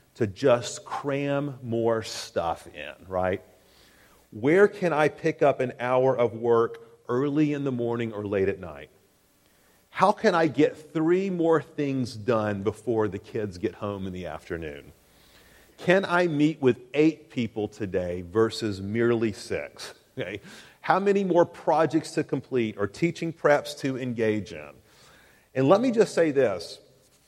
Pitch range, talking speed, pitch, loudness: 110-155 Hz, 150 wpm, 125 Hz, -26 LUFS